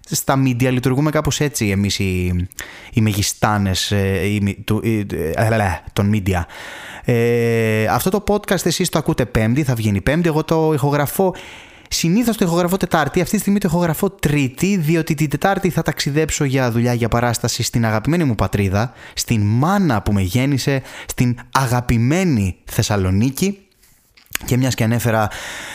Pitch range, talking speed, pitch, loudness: 110-160 Hz, 140 wpm, 125 Hz, -18 LUFS